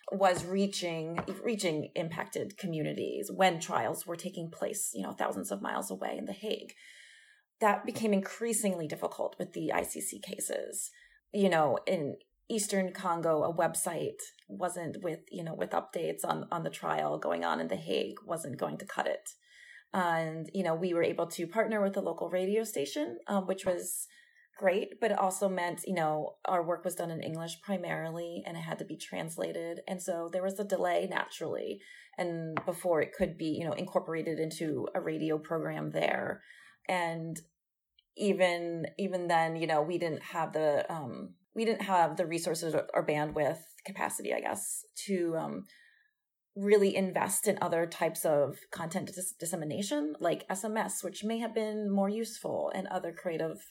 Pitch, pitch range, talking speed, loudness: 185 Hz, 165-210 Hz, 170 wpm, -33 LUFS